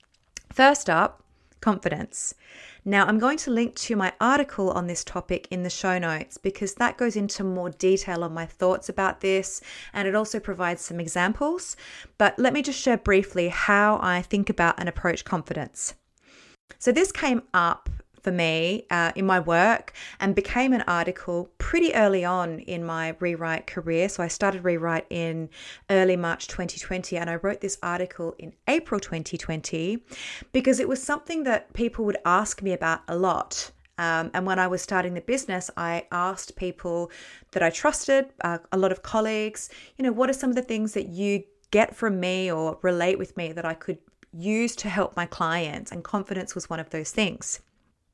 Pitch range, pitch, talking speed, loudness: 175-220 Hz, 190 Hz, 185 wpm, -25 LUFS